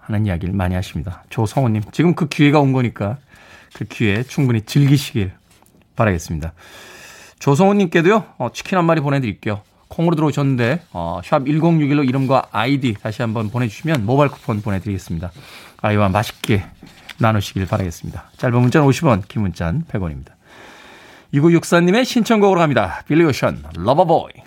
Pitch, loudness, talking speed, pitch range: 120 Hz, -17 LUFS, 365 characters per minute, 100-150 Hz